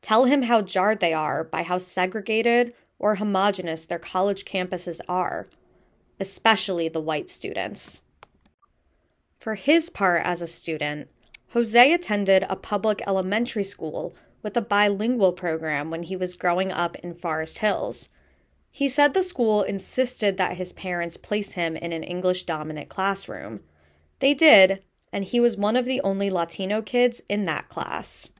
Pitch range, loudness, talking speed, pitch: 175-220 Hz, -24 LUFS, 150 wpm, 195 Hz